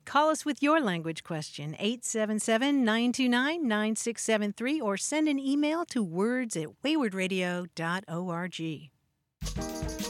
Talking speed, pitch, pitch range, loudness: 100 wpm, 215 Hz, 170-265 Hz, -29 LUFS